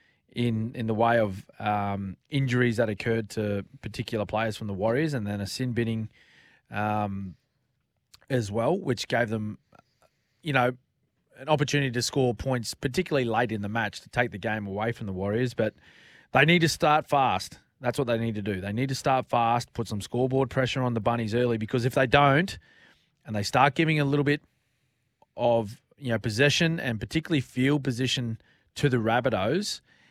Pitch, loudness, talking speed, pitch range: 120 Hz, -27 LUFS, 185 wpm, 110-135 Hz